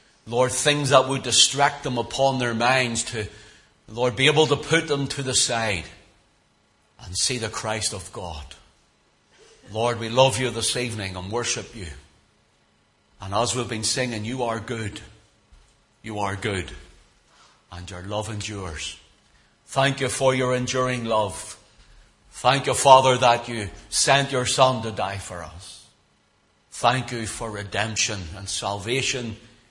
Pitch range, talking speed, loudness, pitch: 100-125 Hz, 145 wpm, -22 LUFS, 115 Hz